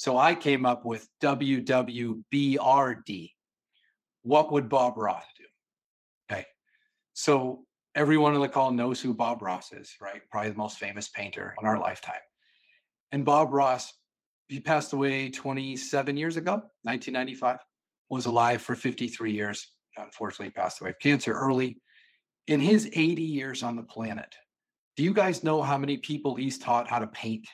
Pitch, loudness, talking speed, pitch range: 135 Hz, -28 LUFS, 155 wpm, 120-145 Hz